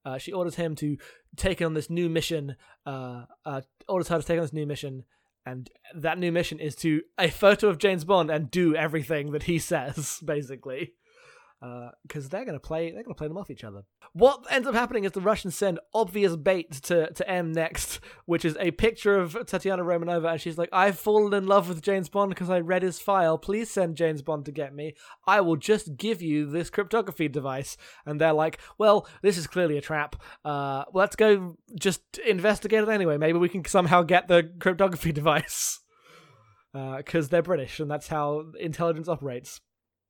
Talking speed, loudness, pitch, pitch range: 205 wpm, -26 LUFS, 170 Hz, 150-195 Hz